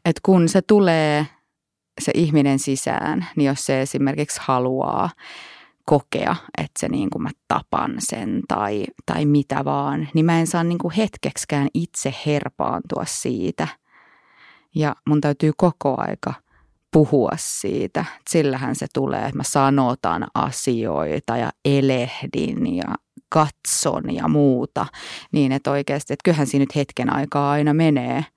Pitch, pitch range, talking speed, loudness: 145 Hz, 140-160 Hz, 140 wpm, -21 LUFS